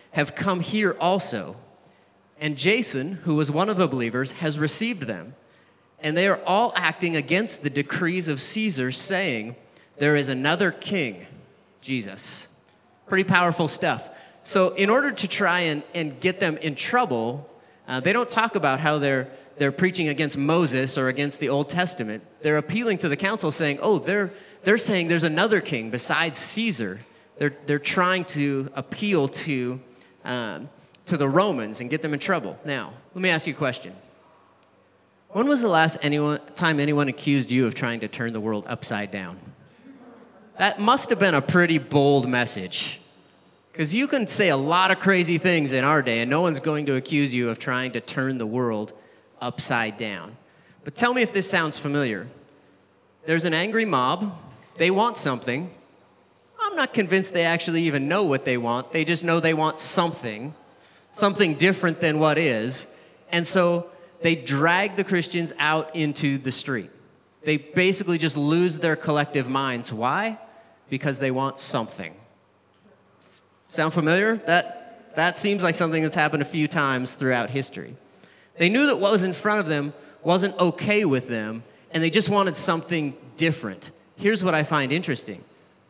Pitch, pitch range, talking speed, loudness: 160 Hz, 135-185 Hz, 170 wpm, -23 LUFS